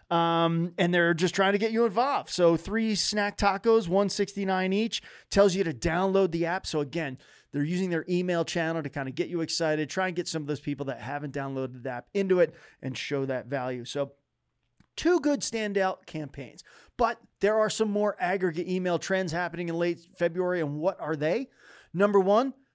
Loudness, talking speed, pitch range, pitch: -28 LUFS, 200 wpm, 155-200 Hz, 175 Hz